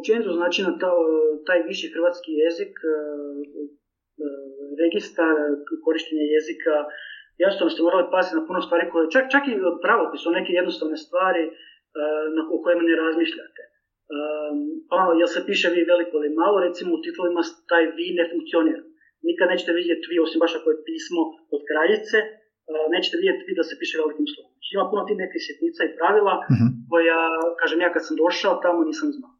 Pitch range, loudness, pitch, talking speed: 160-200 Hz, -22 LUFS, 170 Hz, 165 wpm